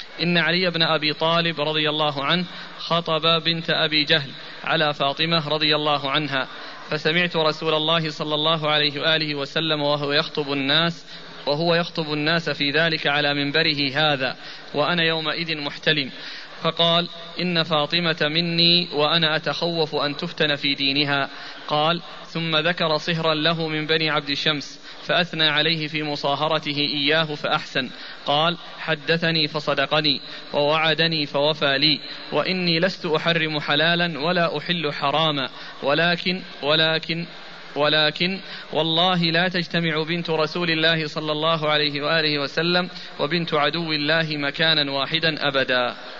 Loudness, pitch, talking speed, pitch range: -21 LUFS, 155 Hz, 125 wpm, 150-165 Hz